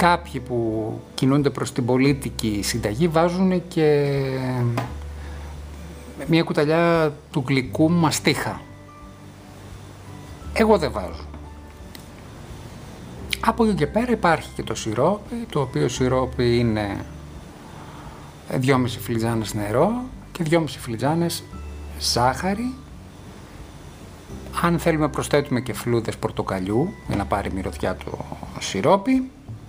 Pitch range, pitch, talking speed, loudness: 100-160 Hz, 125 Hz, 100 wpm, -22 LUFS